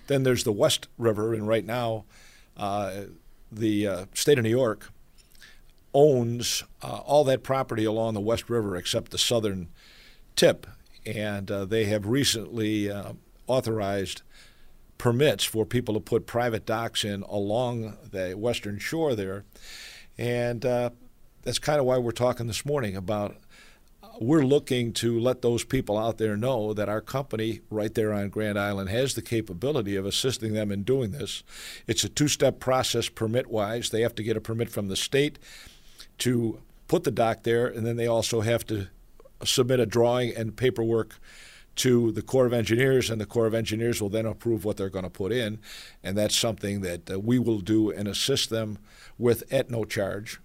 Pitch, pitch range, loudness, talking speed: 115 Hz, 105-120 Hz, -26 LUFS, 180 wpm